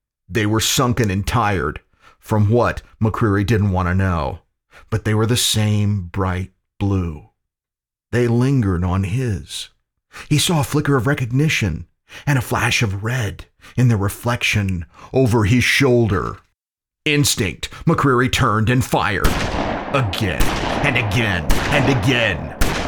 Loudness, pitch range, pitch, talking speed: -18 LUFS, 95-125 Hz, 110 Hz, 130 wpm